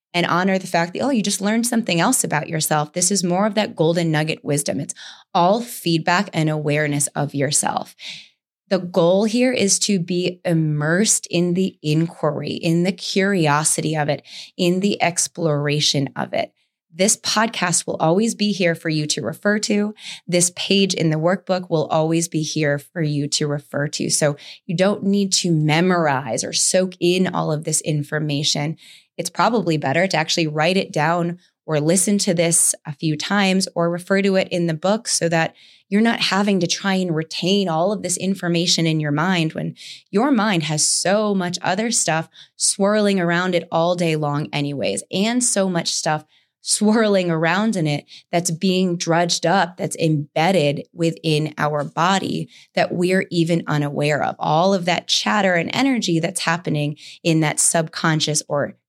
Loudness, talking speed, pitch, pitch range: -19 LUFS, 175 wpm, 170 Hz, 155-195 Hz